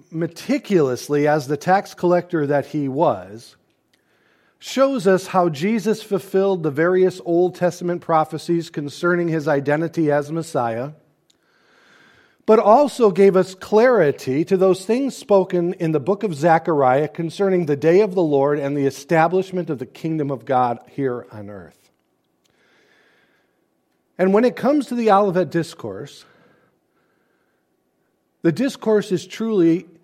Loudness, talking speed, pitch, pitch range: -19 LUFS, 130 wpm, 170 Hz, 150-195 Hz